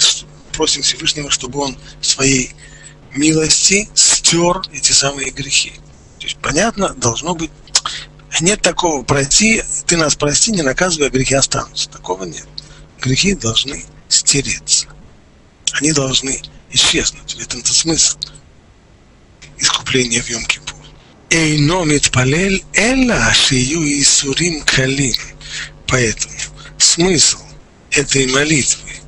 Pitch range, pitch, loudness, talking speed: 135-160 Hz, 145 Hz, -13 LUFS, 95 wpm